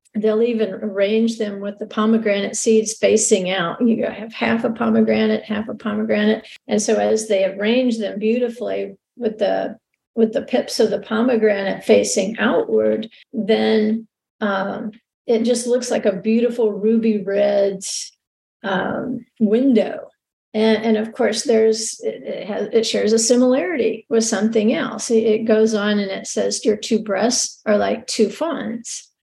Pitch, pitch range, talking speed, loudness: 220 Hz, 210-230 Hz, 155 wpm, -19 LUFS